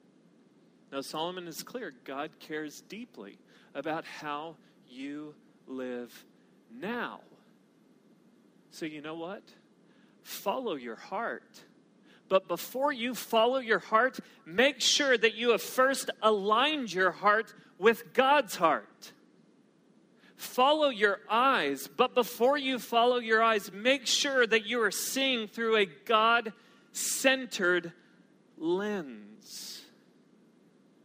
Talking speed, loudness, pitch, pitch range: 110 wpm, -29 LUFS, 225 Hz, 180-250 Hz